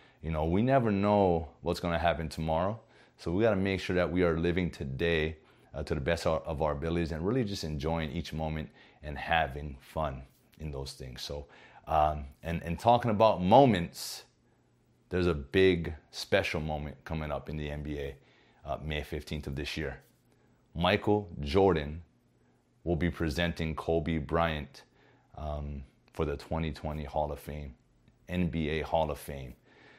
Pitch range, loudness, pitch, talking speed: 75-85 Hz, -31 LUFS, 80 Hz, 170 wpm